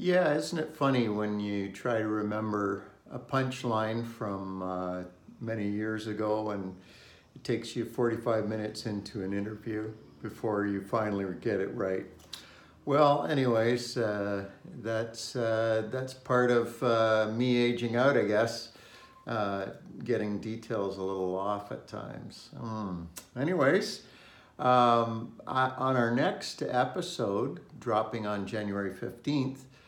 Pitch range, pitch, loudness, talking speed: 100-120 Hz, 110 Hz, -31 LUFS, 130 wpm